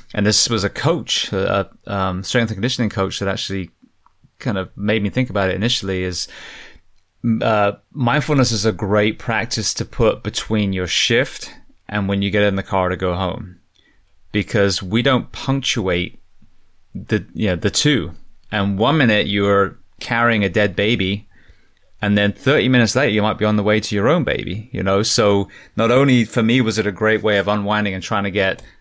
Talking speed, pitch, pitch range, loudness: 195 wpm, 105 Hz, 95-115 Hz, -18 LUFS